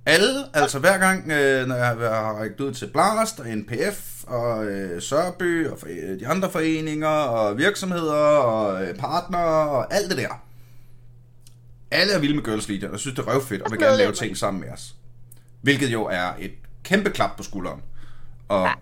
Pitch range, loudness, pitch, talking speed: 120-155 Hz, -22 LUFS, 125 Hz, 170 wpm